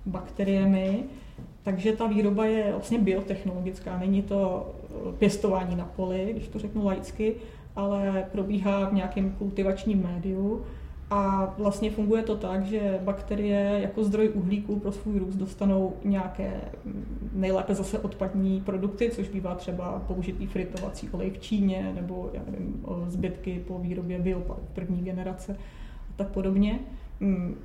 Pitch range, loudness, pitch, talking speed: 190-205 Hz, -29 LUFS, 195 Hz, 130 wpm